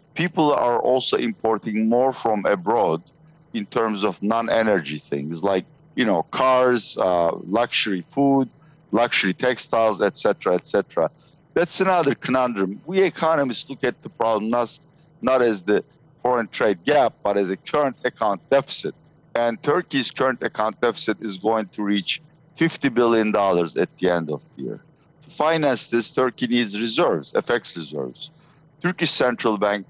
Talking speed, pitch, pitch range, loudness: 155 wpm, 120 Hz, 105-155 Hz, -22 LUFS